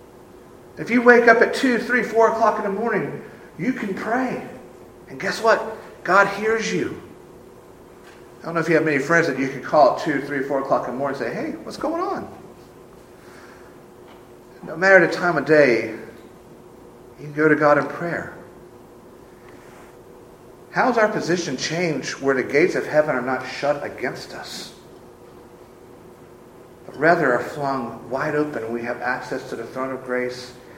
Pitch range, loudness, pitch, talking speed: 130-200 Hz, -20 LUFS, 150 Hz, 175 wpm